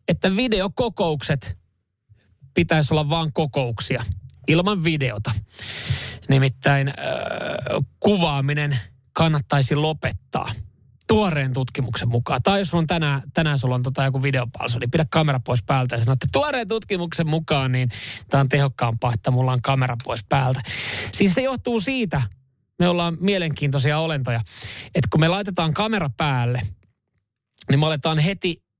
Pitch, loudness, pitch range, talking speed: 140 Hz, -22 LUFS, 120-165 Hz, 130 wpm